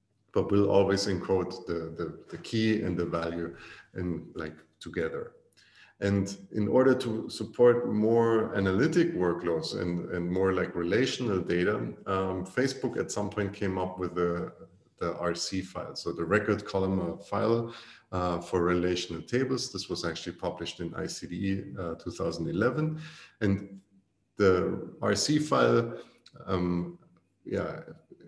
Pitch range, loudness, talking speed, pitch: 90-110 Hz, -30 LUFS, 135 wpm, 95 Hz